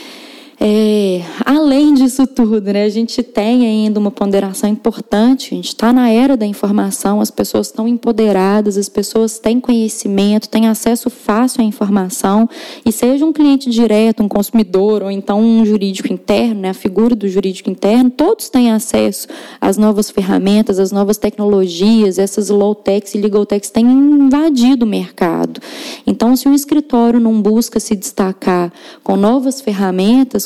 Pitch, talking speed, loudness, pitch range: 220 Hz, 155 wpm, -13 LUFS, 205-245 Hz